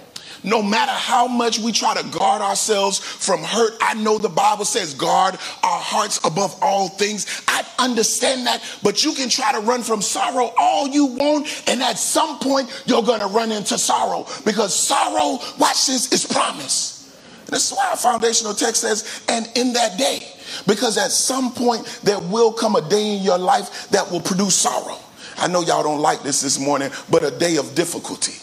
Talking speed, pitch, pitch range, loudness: 190 wpm, 230 Hz, 205-255 Hz, -19 LUFS